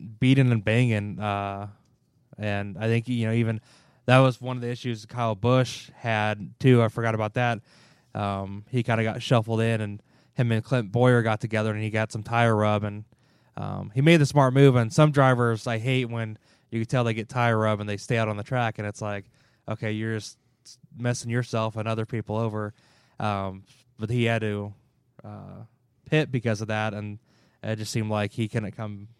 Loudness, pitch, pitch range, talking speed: -25 LUFS, 115 Hz, 110-125 Hz, 210 wpm